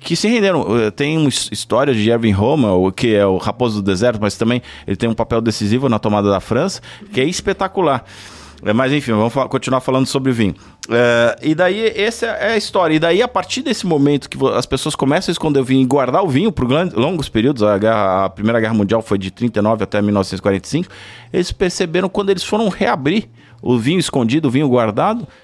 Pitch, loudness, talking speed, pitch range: 125 Hz, -16 LUFS, 205 wpm, 105-155 Hz